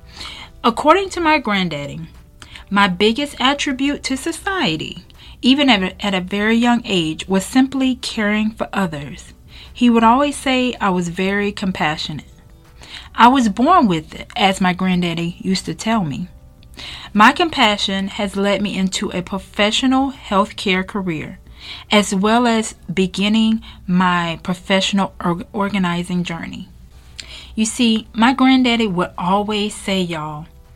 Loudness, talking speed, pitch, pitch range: -17 LUFS, 135 wpm, 200 Hz, 180-235 Hz